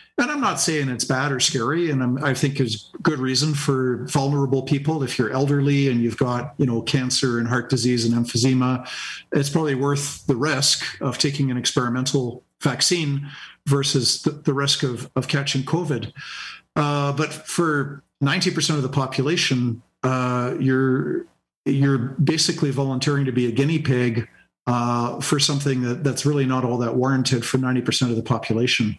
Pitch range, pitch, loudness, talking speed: 125-145 Hz, 135 Hz, -21 LUFS, 170 wpm